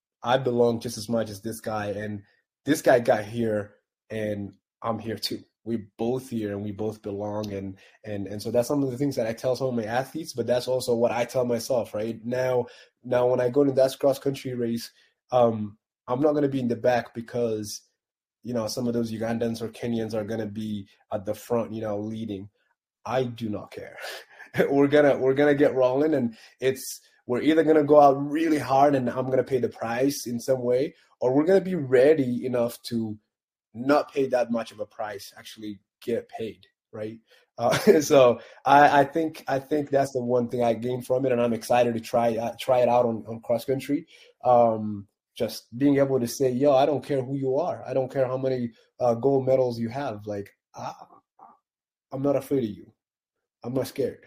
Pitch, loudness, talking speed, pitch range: 120 Hz, -25 LUFS, 220 wpm, 110-135 Hz